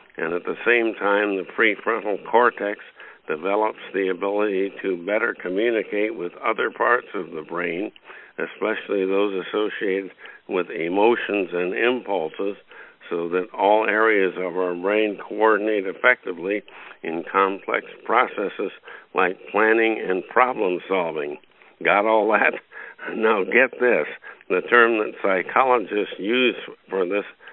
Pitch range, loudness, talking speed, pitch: 95-110 Hz, -22 LUFS, 125 wpm, 100 Hz